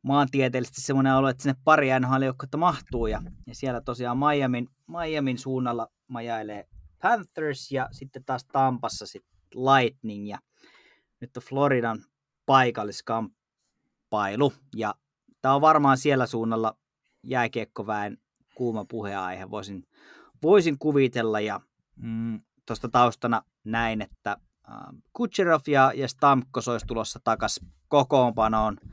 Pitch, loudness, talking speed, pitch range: 125 Hz, -25 LUFS, 110 wpm, 115-135 Hz